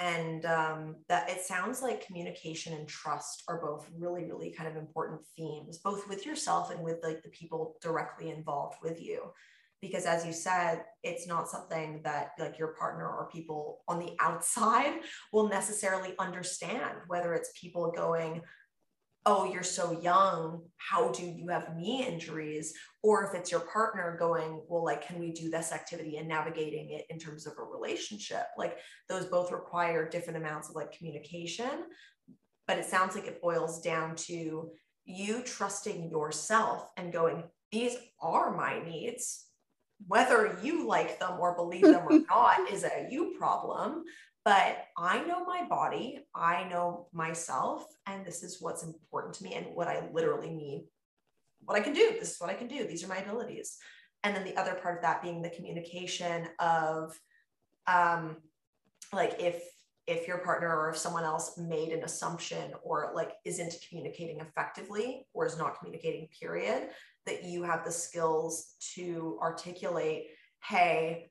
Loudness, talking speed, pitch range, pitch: -33 LUFS, 165 wpm, 160-195 Hz, 170 Hz